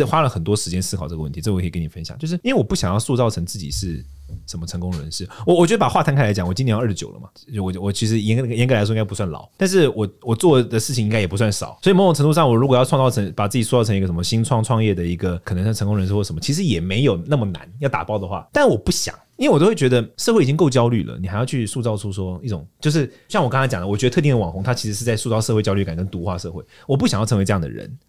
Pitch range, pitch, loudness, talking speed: 95-130 Hz, 110 Hz, -19 LUFS, 455 characters per minute